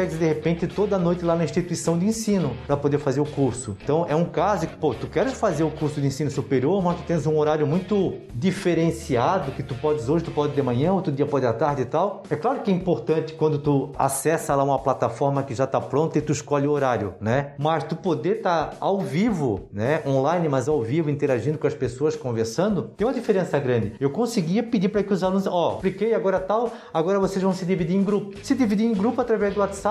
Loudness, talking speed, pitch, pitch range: -23 LUFS, 235 wpm, 160 Hz, 145-190 Hz